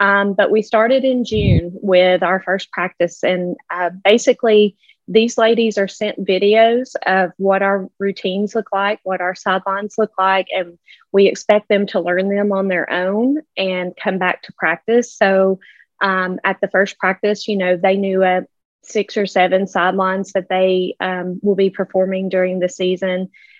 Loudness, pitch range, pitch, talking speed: -17 LUFS, 185-210 Hz, 195 Hz, 175 wpm